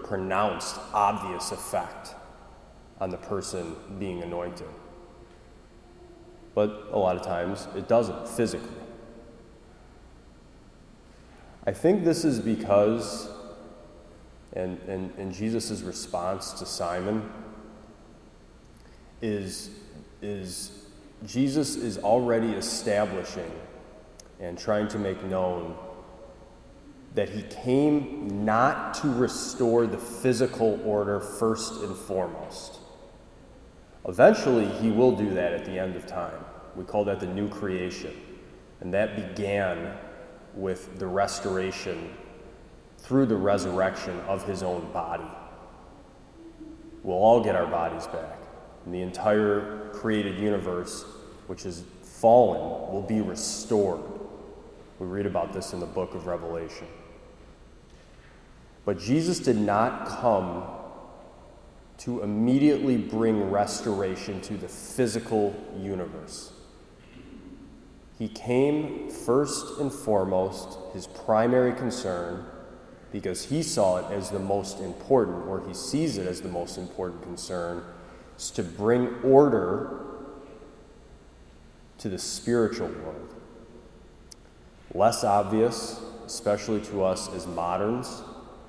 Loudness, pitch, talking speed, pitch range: -27 LUFS, 100 Hz, 110 wpm, 90-115 Hz